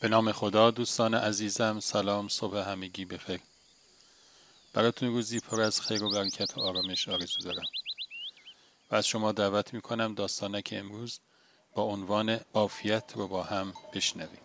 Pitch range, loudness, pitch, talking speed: 100-115 Hz, -30 LUFS, 105 Hz, 145 wpm